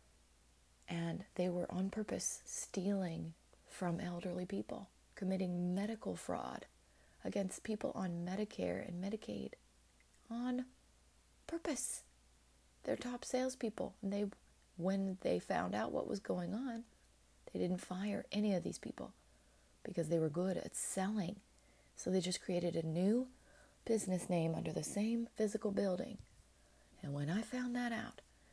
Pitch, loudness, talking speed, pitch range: 185 Hz, -41 LUFS, 135 wpm, 165-215 Hz